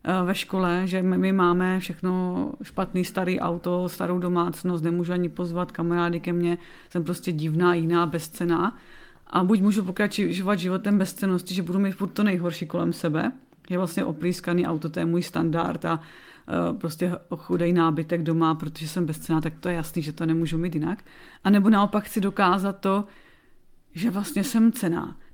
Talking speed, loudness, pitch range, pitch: 170 wpm, -25 LUFS, 170-190 Hz, 180 Hz